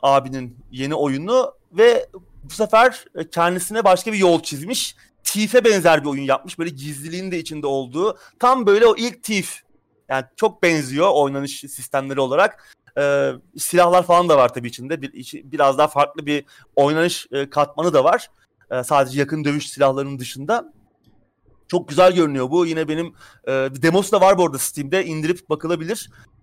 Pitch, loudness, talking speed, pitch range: 155 Hz, -19 LUFS, 160 wpm, 140-185 Hz